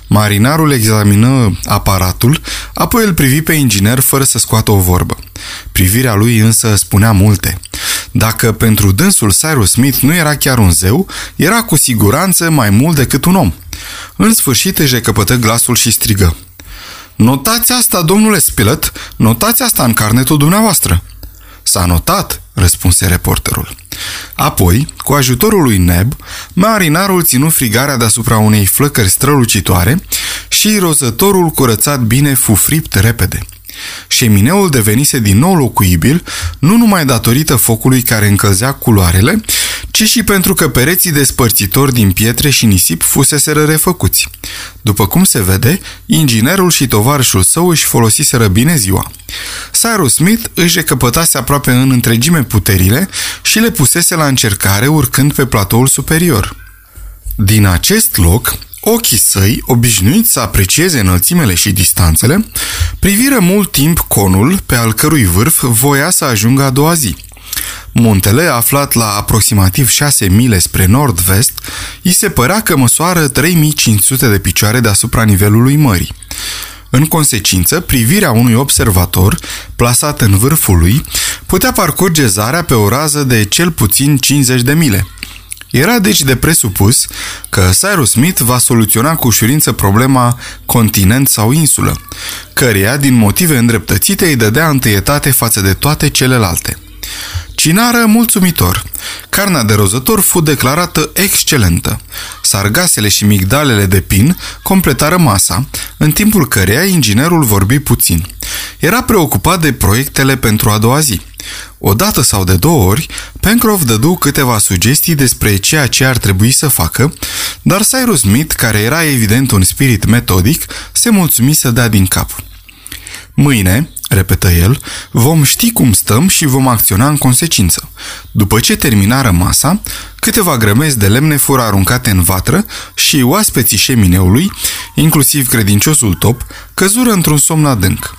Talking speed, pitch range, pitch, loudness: 135 wpm, 100-150 Hz, 120 Hz, -9 LUFS